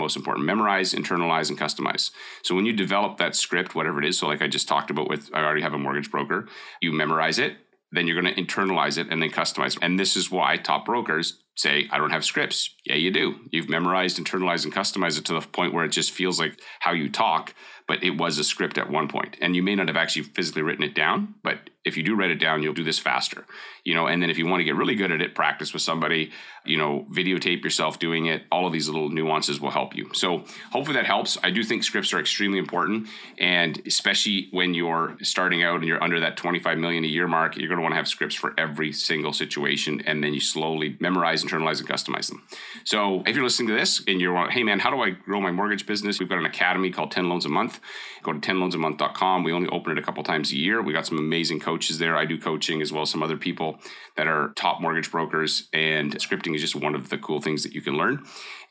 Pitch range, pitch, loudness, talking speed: 75-90 Hz, 85 Hz, -24 LUFS, 255 wpm